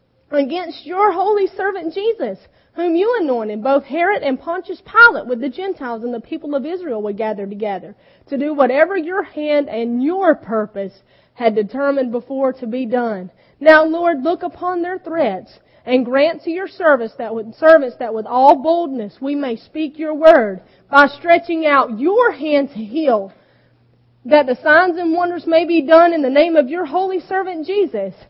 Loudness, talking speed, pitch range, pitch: -16 LUFS, 175 wpm, 245-340 Hz, 300 Hz